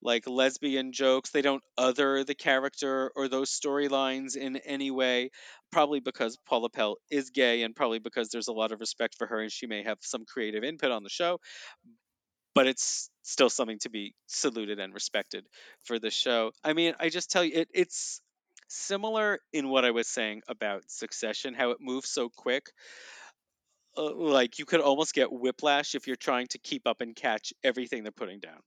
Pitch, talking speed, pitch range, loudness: 135 Hz, 195 wpm, 120-145 Hz, -30 LUFS